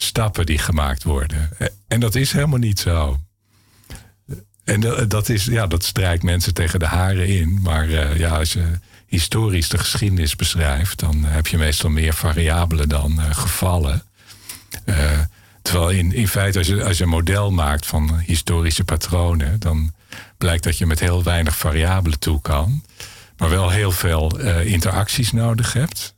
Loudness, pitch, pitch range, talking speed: -19 LUFS, 90 Hz, 80-105 Hz, 165 wpm